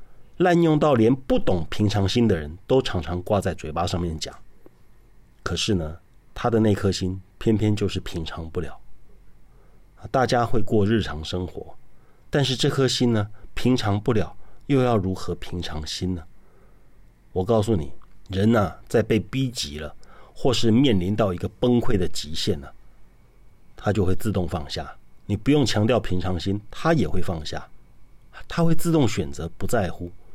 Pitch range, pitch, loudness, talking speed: 90-115 Hz, 100 Hz, -24 LUFS, 235 characters per minute